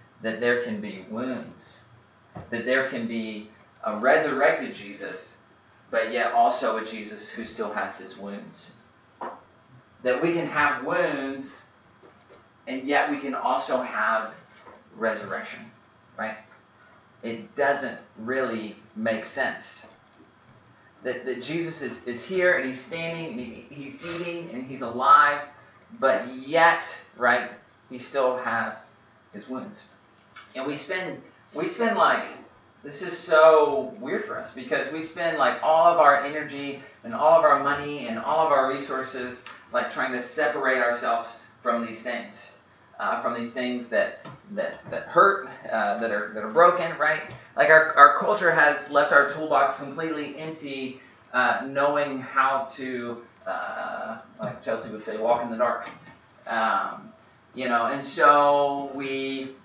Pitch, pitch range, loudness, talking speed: 135 Hz, 120-150 Hz, -24 LUFS, 145 wpm